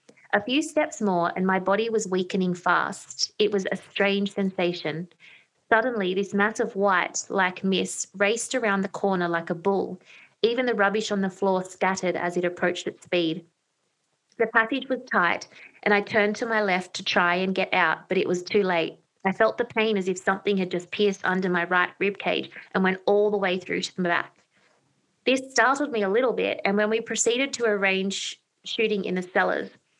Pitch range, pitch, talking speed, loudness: 185-220 Hz, 195 Hz, 200 wpm, -25 LUFS